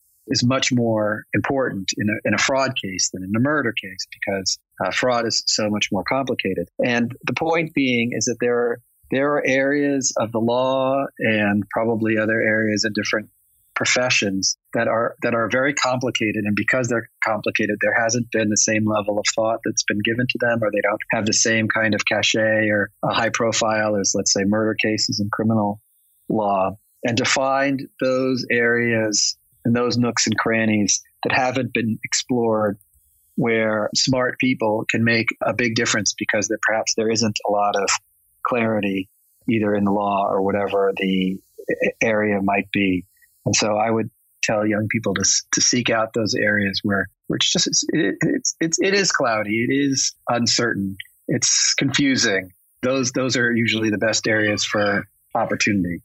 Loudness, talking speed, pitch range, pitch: -20 LUFS, 175 wpm, 105-120 Hz, 110 Hz